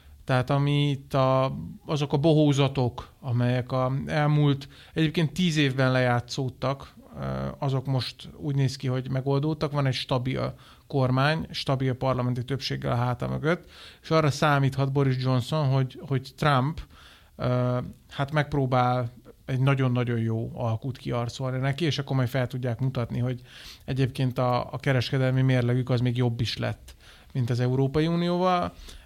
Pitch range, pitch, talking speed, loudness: 125-140 Hz, 130 Hz, 140 wpm, -26 LUFS